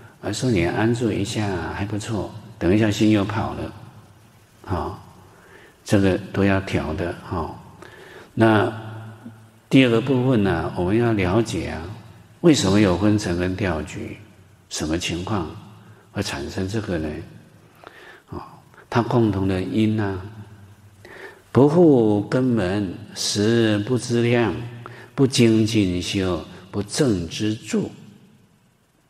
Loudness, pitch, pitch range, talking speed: -21 LUFS, 105 Hz, 95-115 Hz, 175 characters per minute